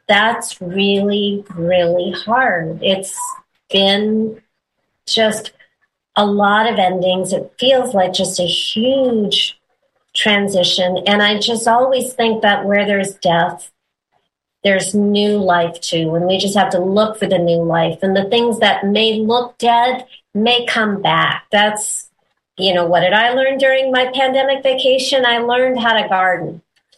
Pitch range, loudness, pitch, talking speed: 185-235 Hz, -15 LUFS, 205 Hz, 150 wpm